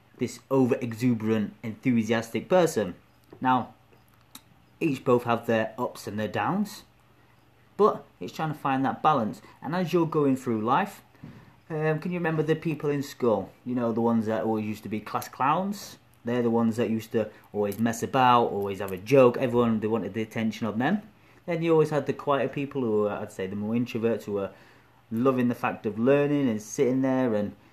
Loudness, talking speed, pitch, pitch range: -27 LUFS, 195 wpm, 120 Hz, 110-140 Hz